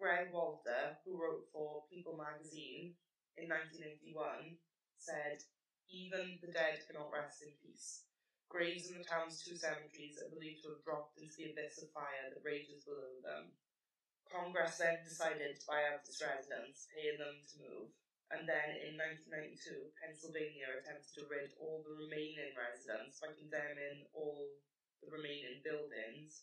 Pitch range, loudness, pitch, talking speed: 150-165 Hz, -45 LUFS, 155 Hz, 150 wpm